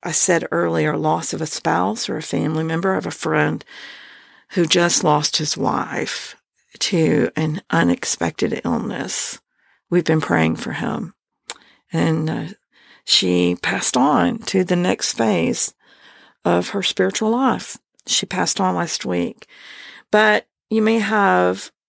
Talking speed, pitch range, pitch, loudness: 135 wpm, 145-200 Hz, 165 Hz, -19 LUFS